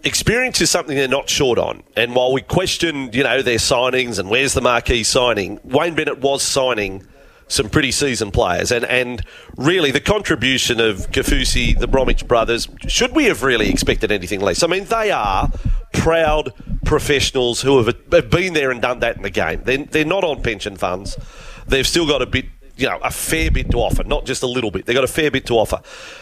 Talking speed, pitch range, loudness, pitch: 205 wpm, 120-155 Hz, -17 LUFS, 135 Hz